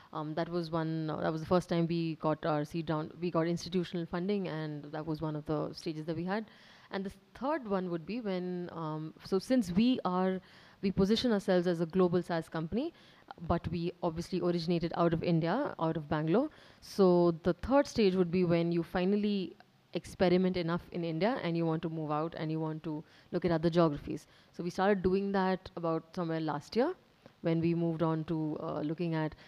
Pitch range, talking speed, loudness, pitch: 160-185 Hz, 210 wpm, -33 LUFS, 170 Hz